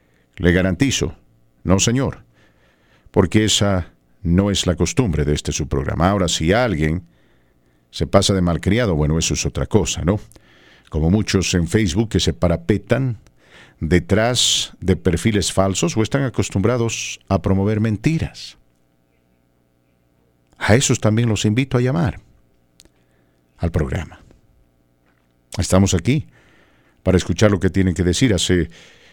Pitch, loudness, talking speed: 90 Hz, -18 LUFS, 130 wpm